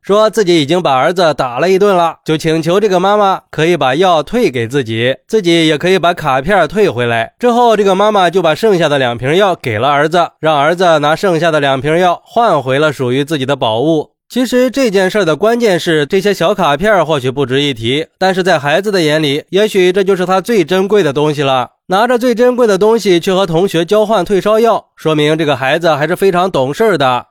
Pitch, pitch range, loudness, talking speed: 175 Hz, 150-205 Hz, -11 LUFS, 325 characters per minute